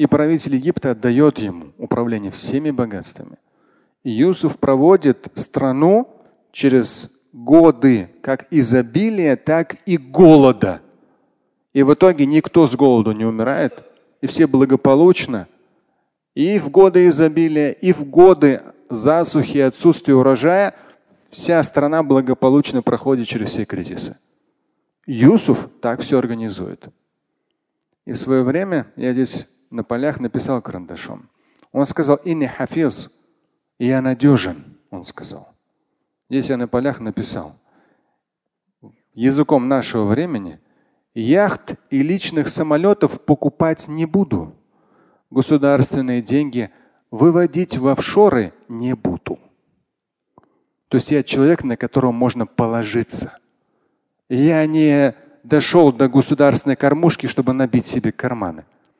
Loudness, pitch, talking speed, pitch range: -16 LUFS, 140 Hz, 110 wpm, 130-160 Hz